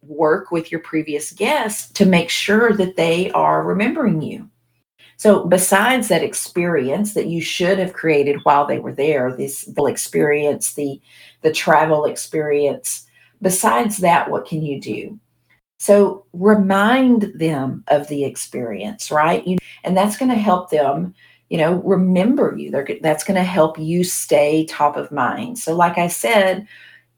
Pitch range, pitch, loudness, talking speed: 150-195 Hz, 175 Hz, -17 LUFS, 155 wpm